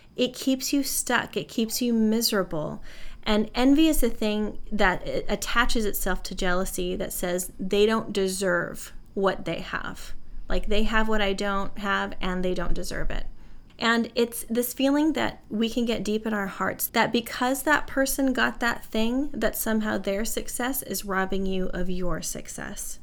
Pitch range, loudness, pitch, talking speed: 190-240 Hz, -26 LUFS, 215 Hz, 175 wpm